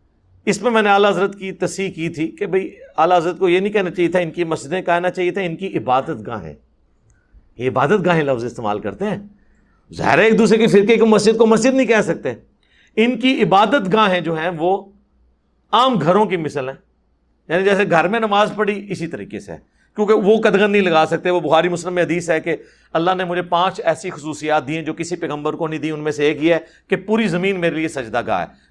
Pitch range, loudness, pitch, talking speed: 160-205 Hz, -17 LUFS, 180 Hz, 235 wpm